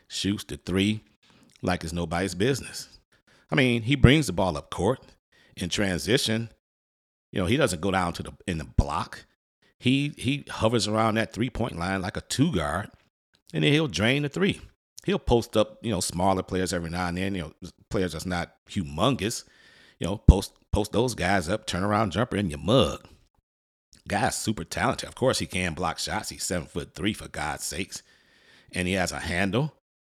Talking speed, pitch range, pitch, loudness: 195 wpm, 85-110 Hz, 95 Hz, -26 LUFS